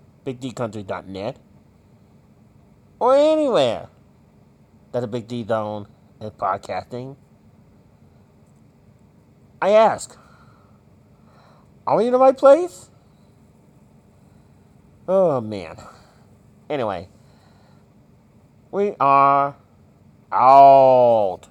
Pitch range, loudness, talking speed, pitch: 110-175 Hz, -18 LUFS, 65 wpm, 130 Hz